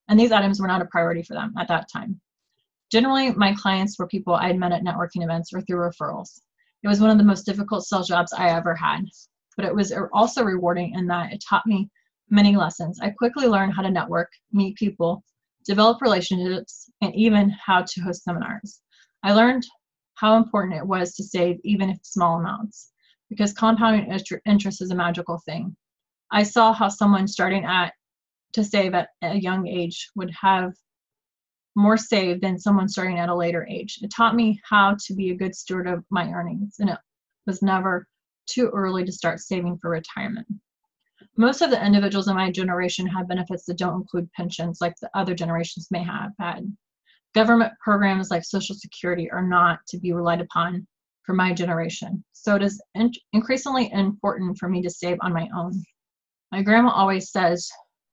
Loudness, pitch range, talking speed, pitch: -22 LUFS, 175-210 Hz, 190 wpm, 195 Hz